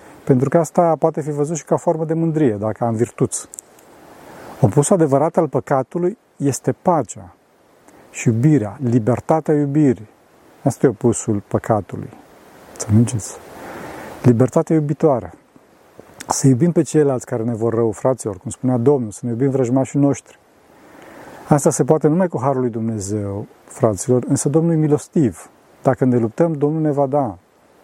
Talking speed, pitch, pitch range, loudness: 145 wpm, 135 Hz, 120-155 Hz, -18 LUFS